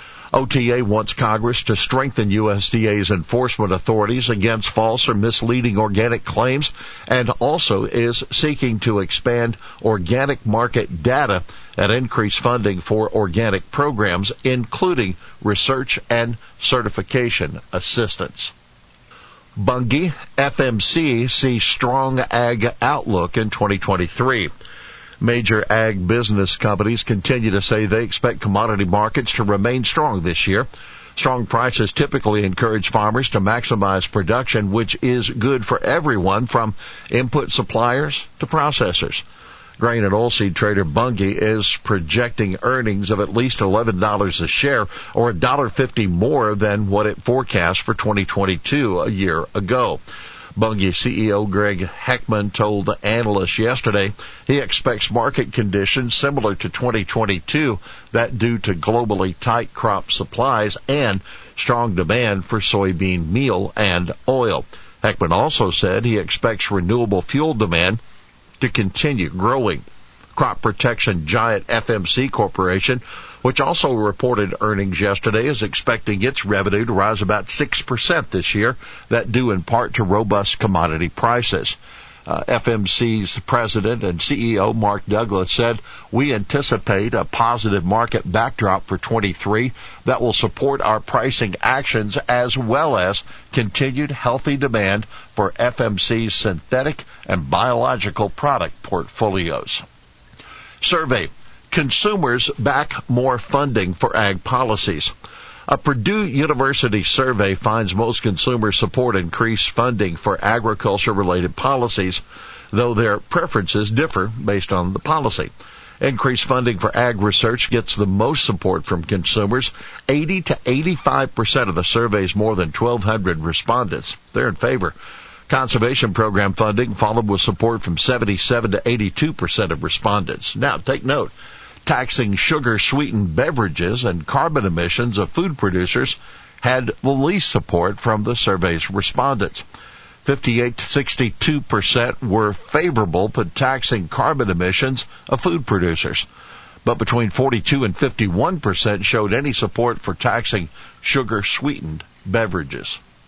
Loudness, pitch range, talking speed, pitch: -18 LUFS, 100-125 Hz, 130 wpm, 110 Hz